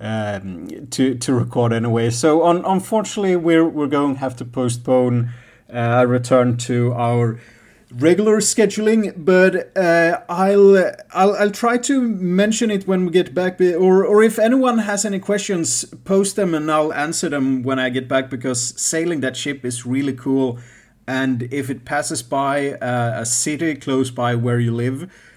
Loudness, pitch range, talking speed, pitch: -18 LUFS, 125-185 Hz, 170 wpm, 140 Hz